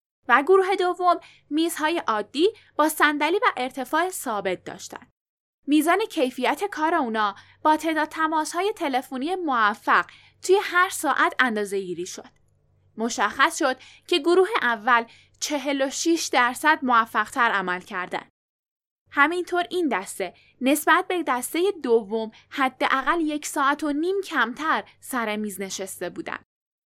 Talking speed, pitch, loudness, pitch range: 125 wpm, 285 Hz, -23 LUFS, 235-335 Hz